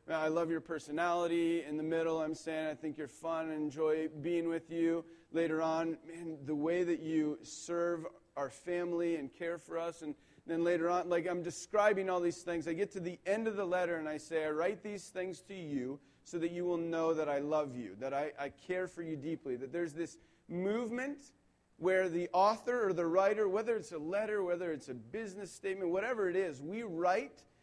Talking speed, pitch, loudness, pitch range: 215 wpm, 170 Hz, -36 LUFS, 155-180 Hz